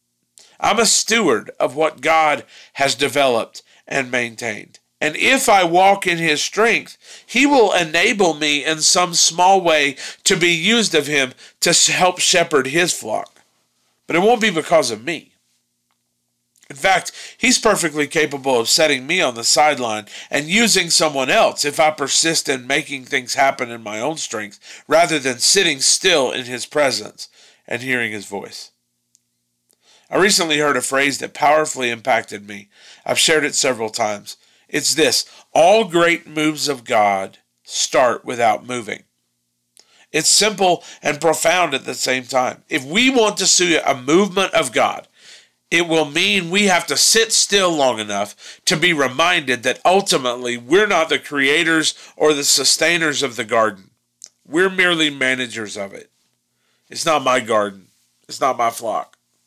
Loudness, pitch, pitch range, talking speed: -16 LUFS, 145 Hz, 120-170 Hz, 160 wpm